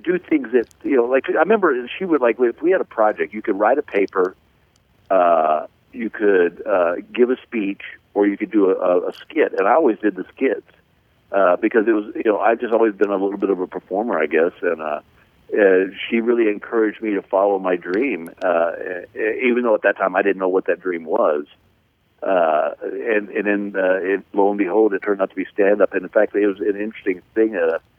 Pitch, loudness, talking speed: 105 Hz, -19 LUFS, 230 wpm